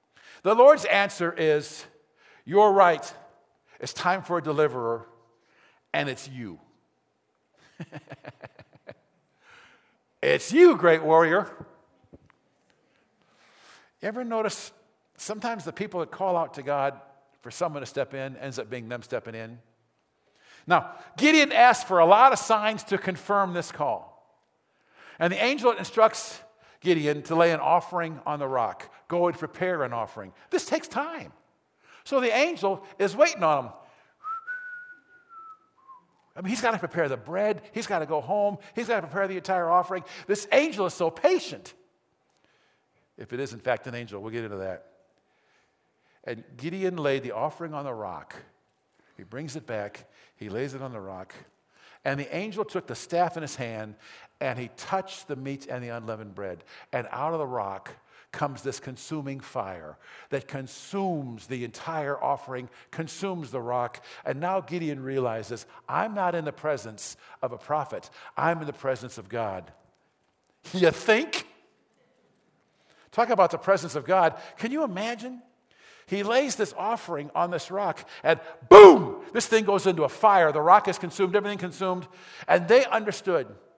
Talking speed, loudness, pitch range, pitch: 160 wpm, -24 LUFS, 135-210 Hz, 170 Hz